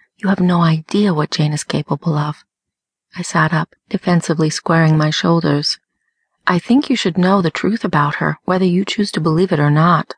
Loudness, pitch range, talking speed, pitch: -16 LUFS, 155-195 Hz, 195 wpm, 175 Hz